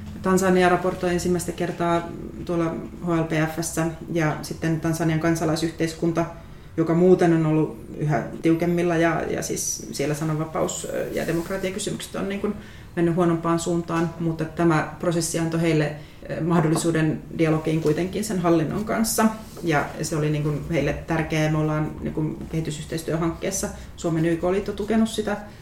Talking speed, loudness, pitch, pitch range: 130 wpm, -24 LUFS, 165 Hz, 160-175 Hz